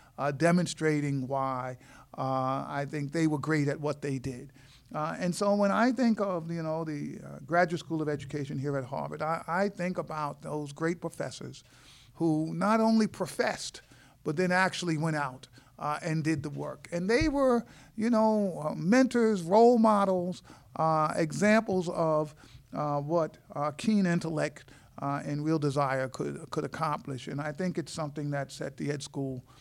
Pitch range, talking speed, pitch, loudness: 140-180 Hz, 175 wpm, 155 Hz, -30 LUFS